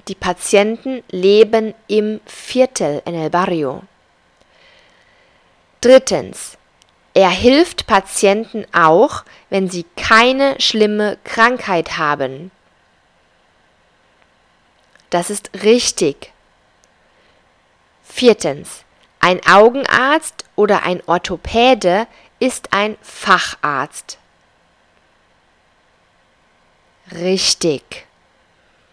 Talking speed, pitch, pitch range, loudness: 65 wpm, 200 Hz, 175-230 Hz, -14 LUFS